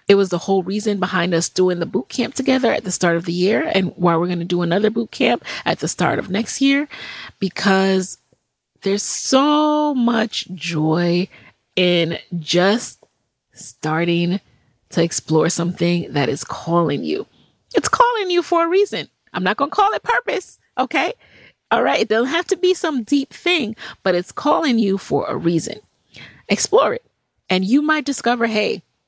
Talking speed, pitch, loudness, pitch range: 180 wpm, 195 Hz, -19 LUFS, 175-270 Hz